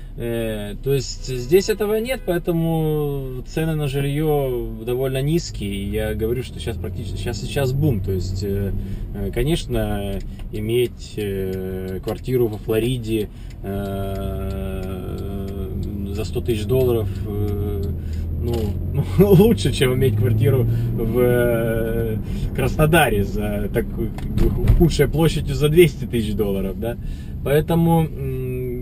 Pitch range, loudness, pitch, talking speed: 100-135 Hz, -21 LUFS, 115 Hz, 100 wpm